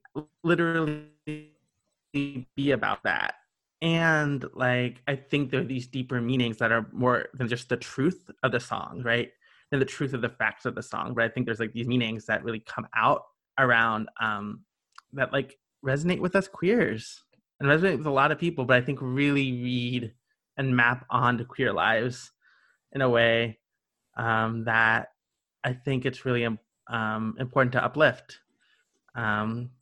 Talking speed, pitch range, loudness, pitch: 165 wpm, 115-140 Hz, -27 LUFS, 125 Hz